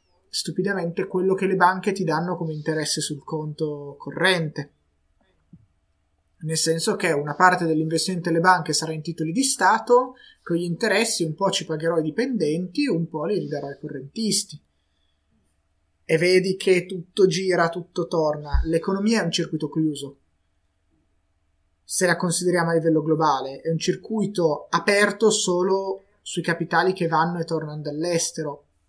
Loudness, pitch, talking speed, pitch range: -22 LUFS, 165 Hz, 145 wpm, 150-185 Hz